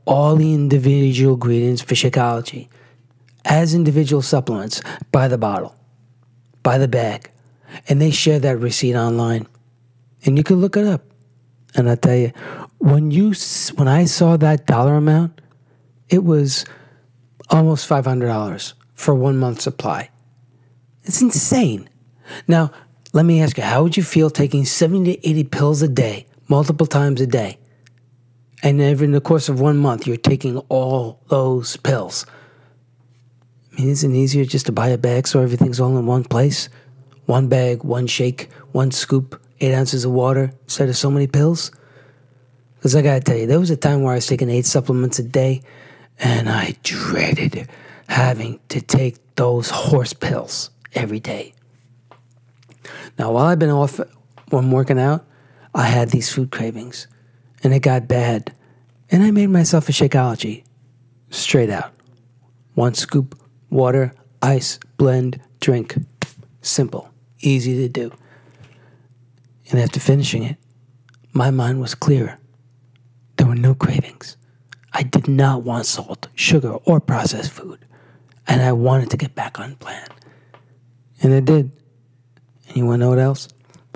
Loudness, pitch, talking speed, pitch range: -17 LUFS, 130 Hz, 150 wpm, 125-145 Hz